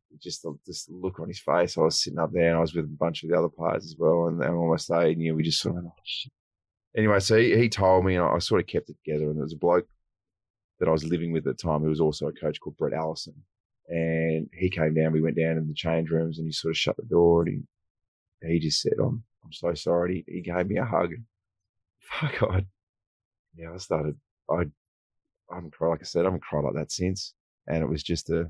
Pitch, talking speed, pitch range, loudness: 85 Hz, 270 wpm, 80-95 Hz, -26 LUFS